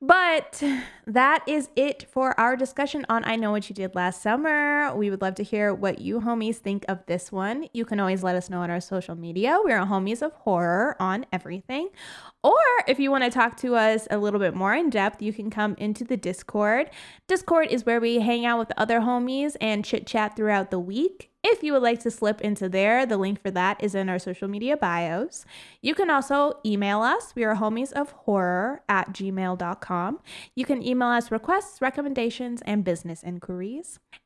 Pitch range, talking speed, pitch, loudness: 195-265 Hz, 205 wpm, 225 Hz, -25 LUFS